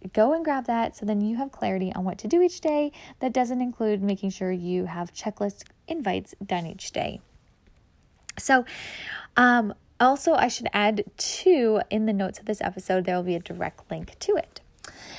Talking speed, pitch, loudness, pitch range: 190 wpm, 215 Hz, -26 LUFS, 190-255 Hz